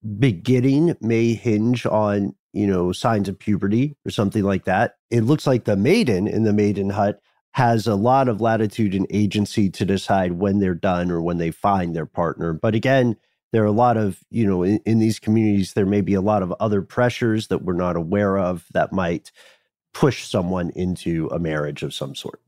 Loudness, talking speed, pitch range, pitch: -21 LUFS, 205 wpm, 95-115 Hz, 105 Hz